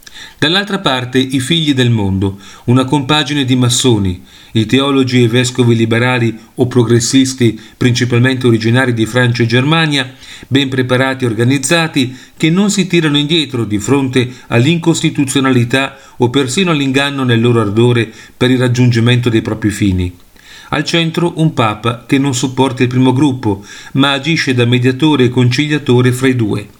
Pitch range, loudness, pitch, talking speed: 120-140 Hz, -12 LUFS, 130 Hz, 150 wpm